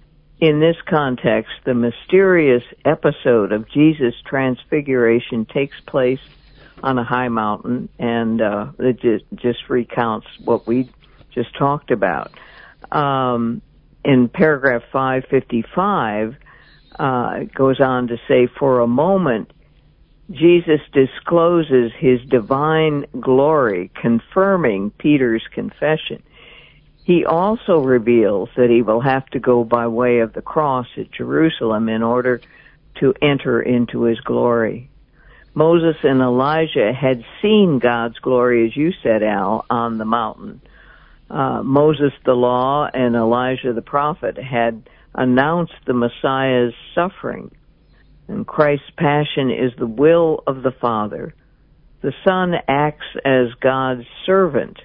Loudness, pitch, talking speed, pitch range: -17 LUFS, 130 Hz, 125 wpm, 120-150 Hz